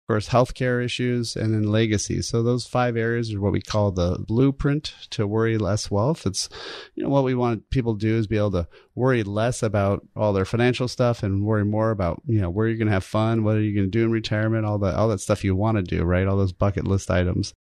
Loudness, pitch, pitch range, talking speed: -23 LUFS, 110 Hz, 100-120 Hz, 250 wpm